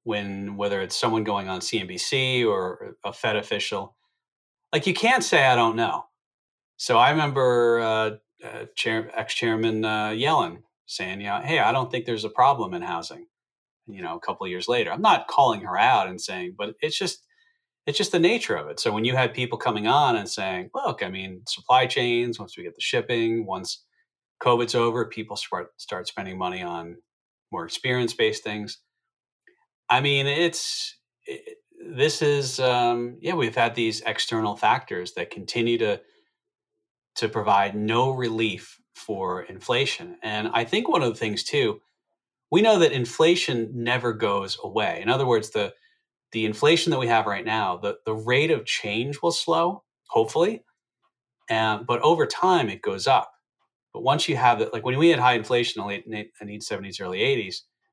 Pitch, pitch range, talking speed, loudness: 120 Hz, 110-175 Hz, 185 wpm, -24 LUFS